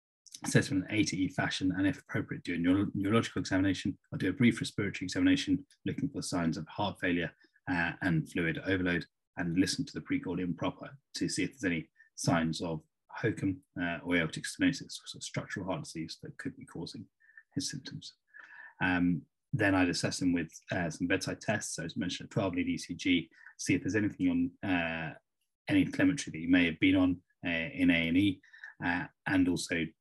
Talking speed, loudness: 200 wpm, -32 LUFS